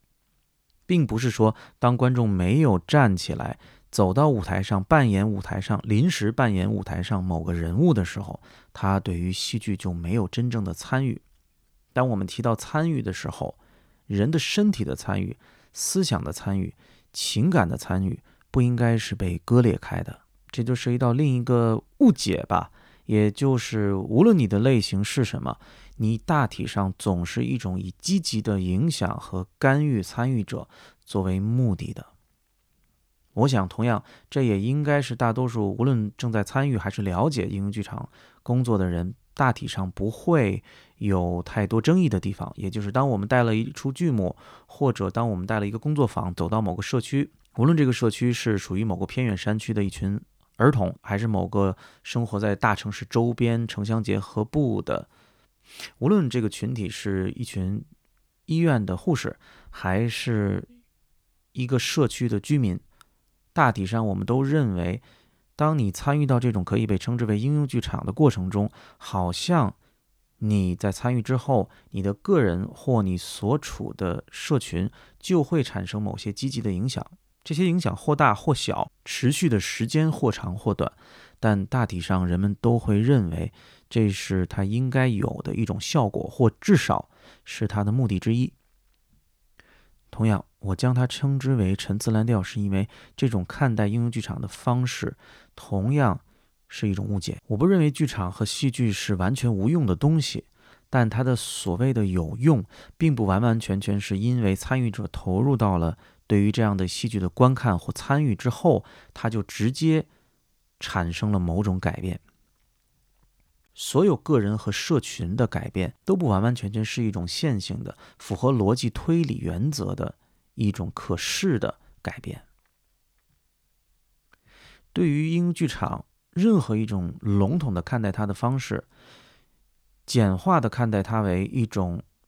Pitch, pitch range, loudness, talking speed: 110 Hz, 100-125 Hz, -25 LUFS, 245 characters per minute